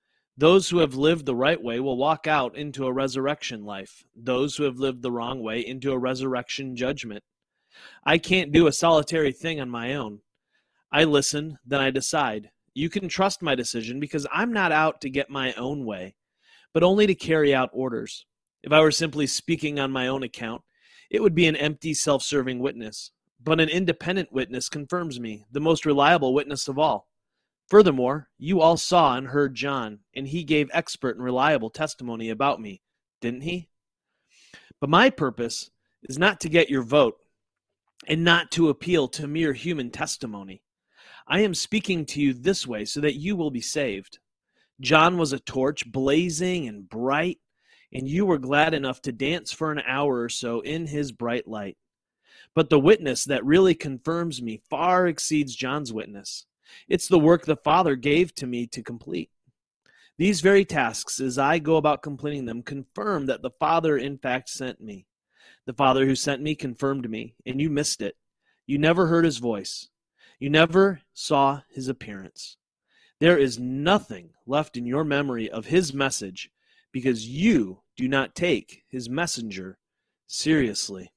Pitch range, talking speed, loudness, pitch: 130-160 Hz, 175 wpm, -24 LUFS, 140 Hz